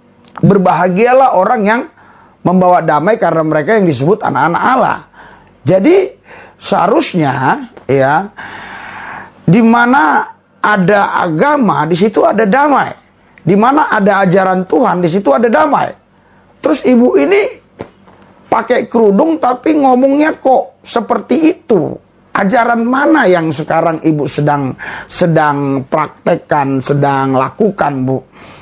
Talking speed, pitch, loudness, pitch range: 110 wpm, 200 Hz, -11 LUFS, 160-245 Hz